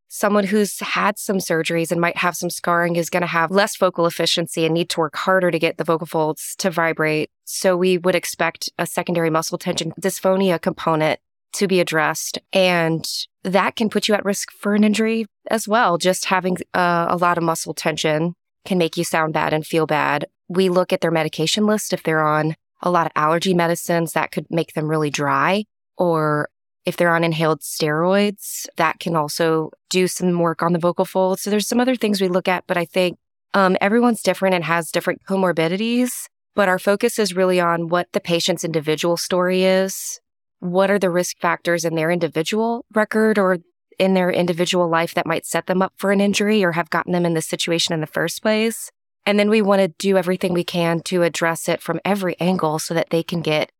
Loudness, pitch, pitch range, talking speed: -19 LUFS, 175 Hz, 165-190 Hz, 210 wpm